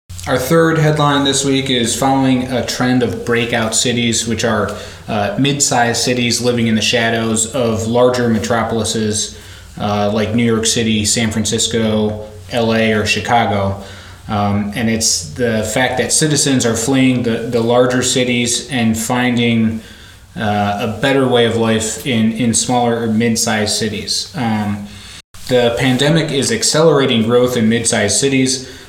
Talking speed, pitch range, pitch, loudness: 150 wpm, 110-125 Hz, 115 Hz, -14 LUFS